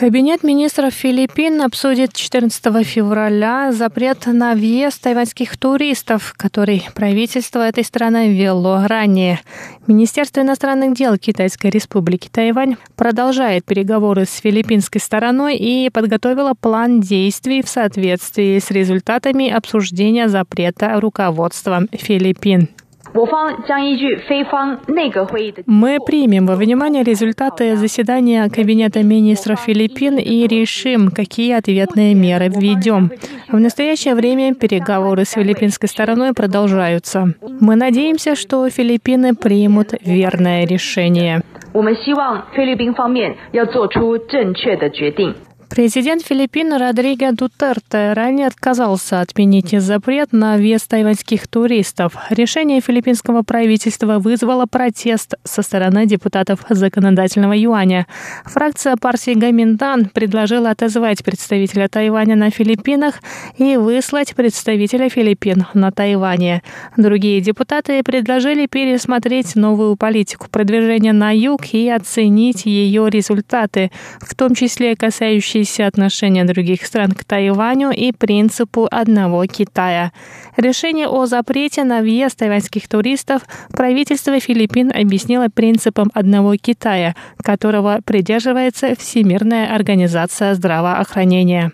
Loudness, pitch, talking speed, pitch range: -14 LUFS, 225 Hz, 100 wpm, 205-250 Hz